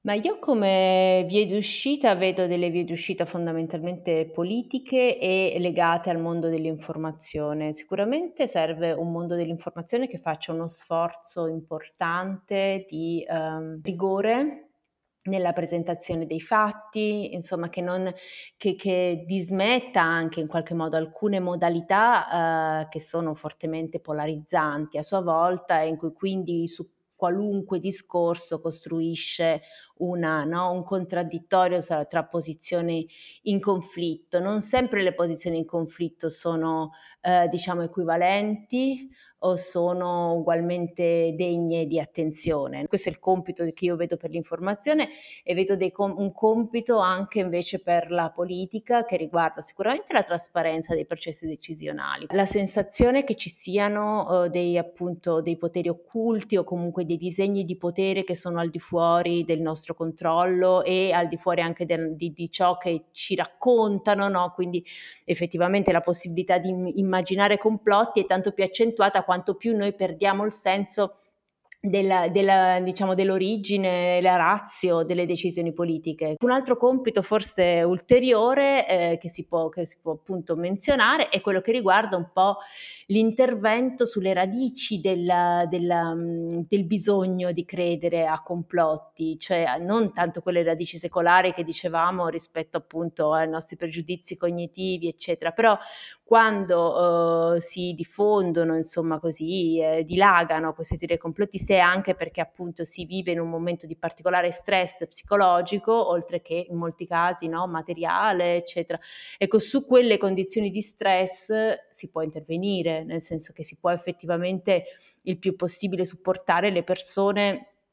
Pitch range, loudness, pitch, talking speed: 170-195 Hz, -25 LUFS, 175 Hz, 140 wpm